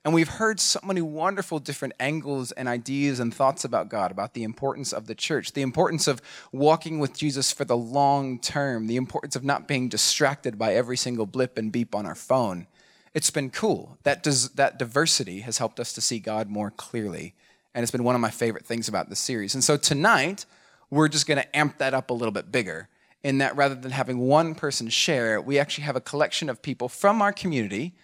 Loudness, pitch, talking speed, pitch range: -25 LUFS, 135 Hz, 220 wpm, 120-150 Hz